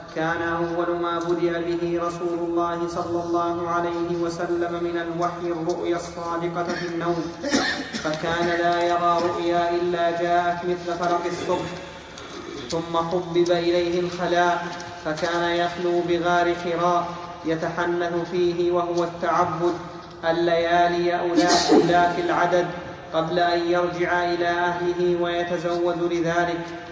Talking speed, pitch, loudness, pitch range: 110 wpm, 175 Hz, -23 LUFS, 170-175 Hz